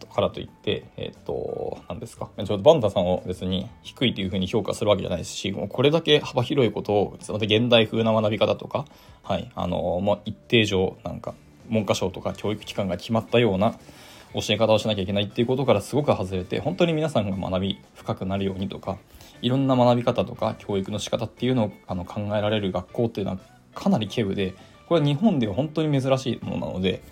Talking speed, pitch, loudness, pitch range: 405 characters per minute, 110 Hz, -24 LUFS, 95-120 Hz